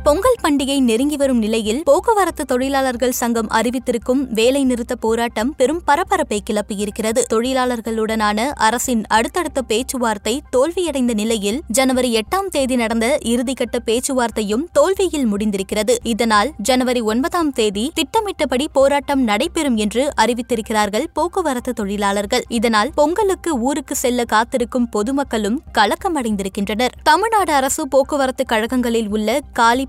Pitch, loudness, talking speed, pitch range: 250 Hz, -18 LUFS, 105 wpm, 225-285 Hz